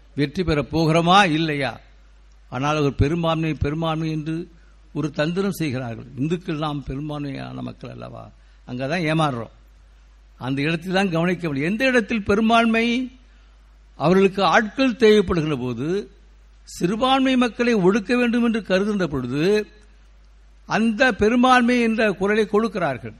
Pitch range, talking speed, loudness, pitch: 130-210 Hz, 110 wpm, -20 LUFS, 160 Hz